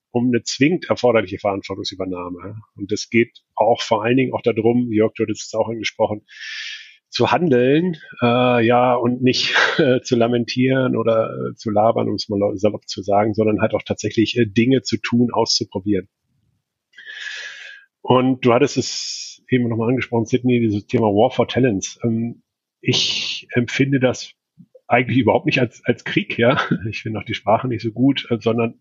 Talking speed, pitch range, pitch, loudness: 170 wpm, 105-125 Hz, 115 Hz, -19 LUFS